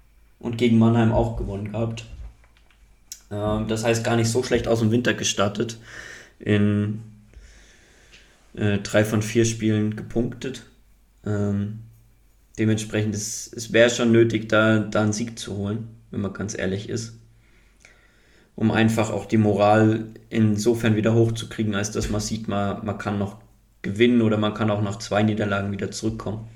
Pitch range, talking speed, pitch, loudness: 105-115 Hz, 145 wpm, 110 Hz, -23 LUFS